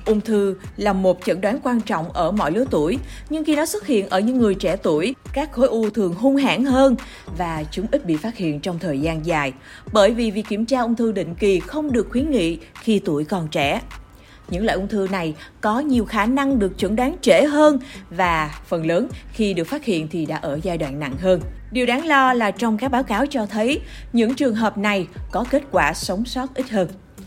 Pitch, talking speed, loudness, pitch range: 210 Hz, 230 wpm, -20 LUFS, 180-255 Hz